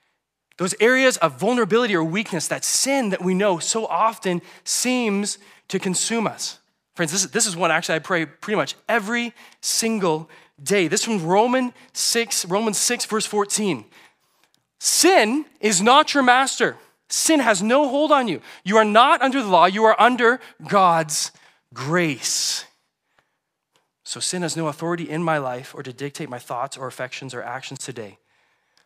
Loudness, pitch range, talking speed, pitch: -20 LUFS, 165-235 Hz, 160 wpm, 205 Hz